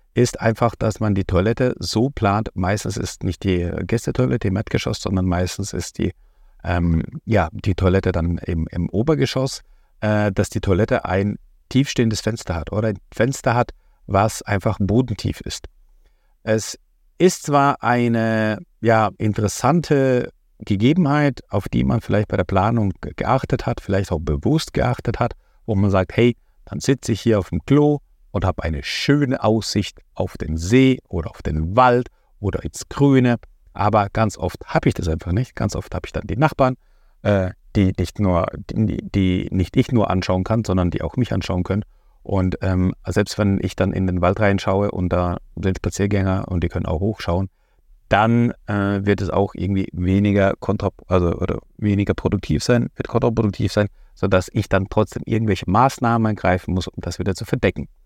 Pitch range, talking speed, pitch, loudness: 95-115 Hz, 175 wpm, 100 Hz, -20 LUFS